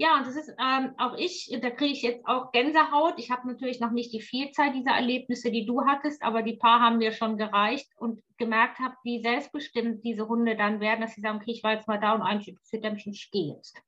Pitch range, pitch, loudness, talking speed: 225-260 Hz, 235 Hz, -27 LUFS, 240 wpm